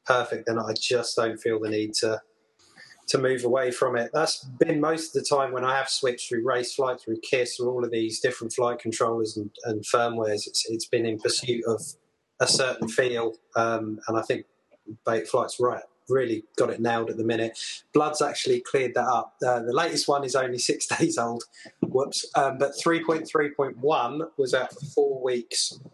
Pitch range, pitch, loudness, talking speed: 115-150 Hz, 125 Hz, -26 LUFS, 205 wpm